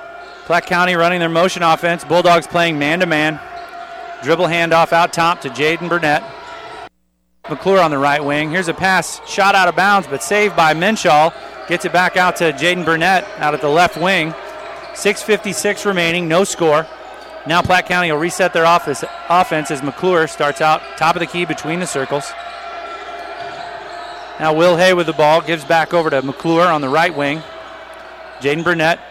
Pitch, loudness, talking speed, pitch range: 170 Hz, -15 LUFS, 175 wpm, 155-185 Hz